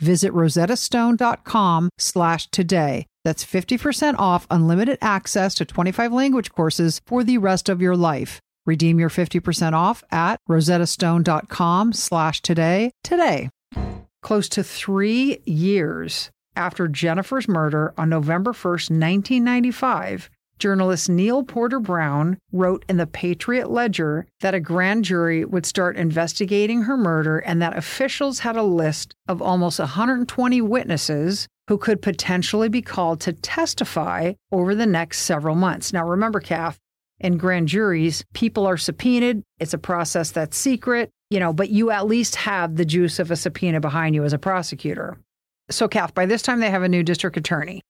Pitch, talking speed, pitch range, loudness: 185 Hz, 145 wpm, 170-220 Hz, -21 LUFS